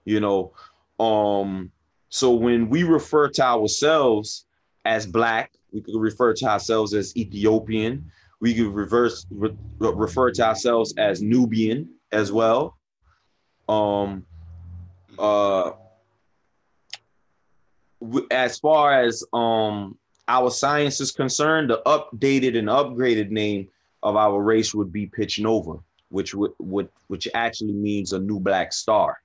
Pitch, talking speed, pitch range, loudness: 110 Hz, 125 wpm, 100-120 Hz, -22 LUFS